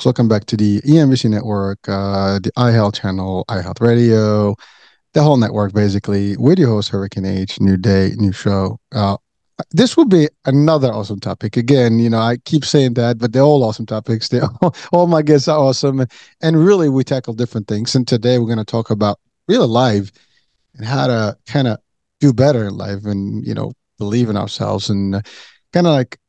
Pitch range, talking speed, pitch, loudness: 100-130 Hz, 195 wpm, 115 Hz, -15 LUFS